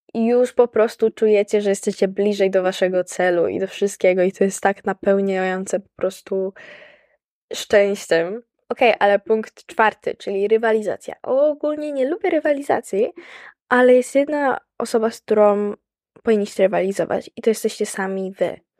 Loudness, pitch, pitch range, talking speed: -19 LUFS, 210 Hz, 195-245 Hz, 150 wpm